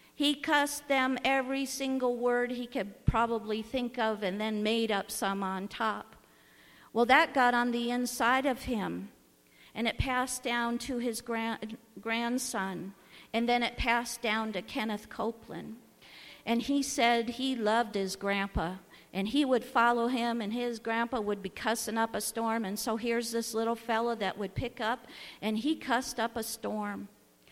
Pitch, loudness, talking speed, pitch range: 230 Hz, -31 LUFS, 170 wpm, 215-245 Hz